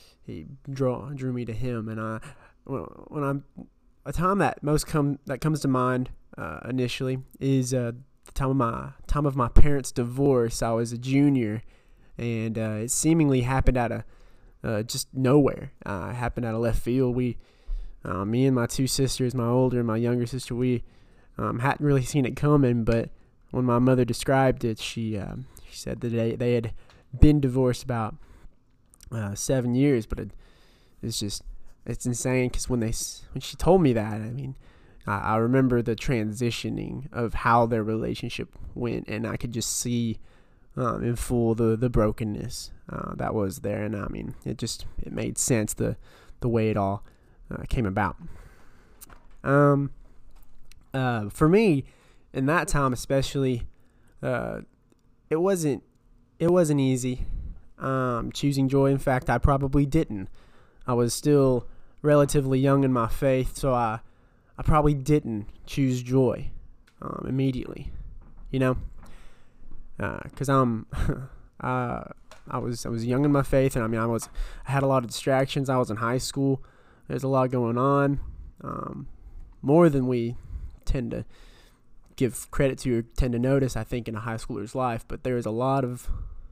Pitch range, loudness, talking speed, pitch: 115-135 Hz, -26 LUFS, 175 wpm, 125 Hz